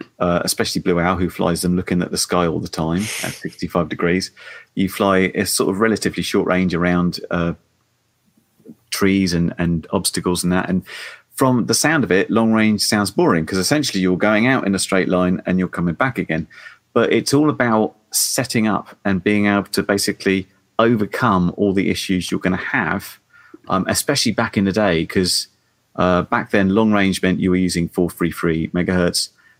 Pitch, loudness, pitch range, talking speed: 95 Hz, -18 LUFS, 90-105 Hz, 190 wpm